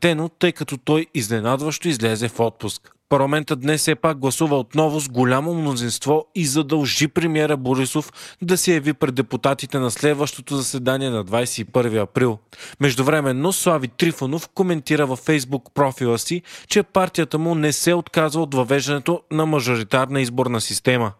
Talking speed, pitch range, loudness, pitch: 150 wpm, 130-155 Hz, -20 LUFS, 145 Hz